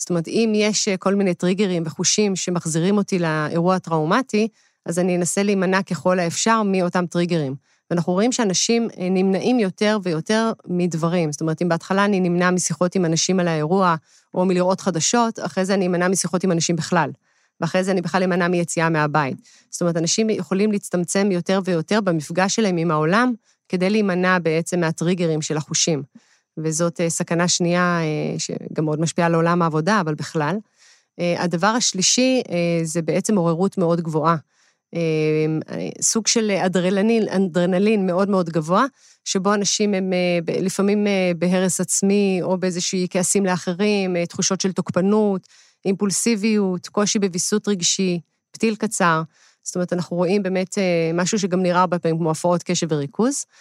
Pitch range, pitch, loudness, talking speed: 170-200 Hz, 180 Hz, -20 LUFS, 145 wpm